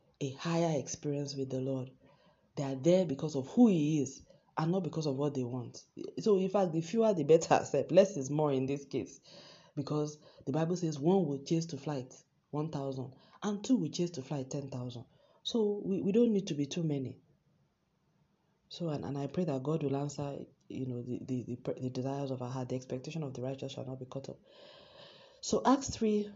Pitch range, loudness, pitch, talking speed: 135-175 Hz, -34 LUFS, 150 Hz, 210 wpm